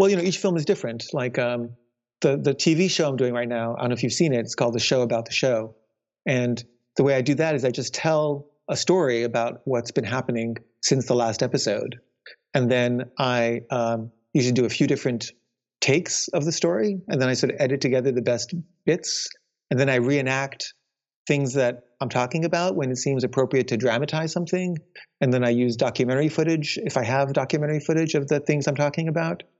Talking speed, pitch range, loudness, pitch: 215 wpm, 120-150 Hz, -23 LUFS, 135 Hz